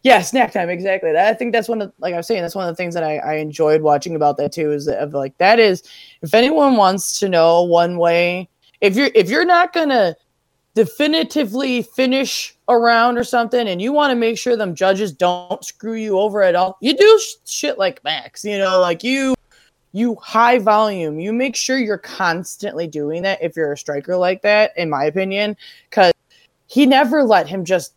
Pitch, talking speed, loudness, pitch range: 205 Hz, 210 wpm, -17 LUFS, 175-245 Hz